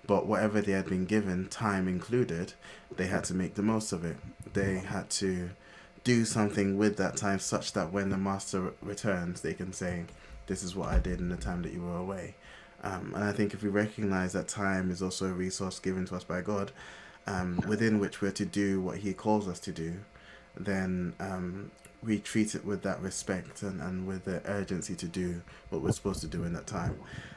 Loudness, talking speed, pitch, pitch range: -33 LUFS, 215 wpm, 95 Hz, 90-100 Hz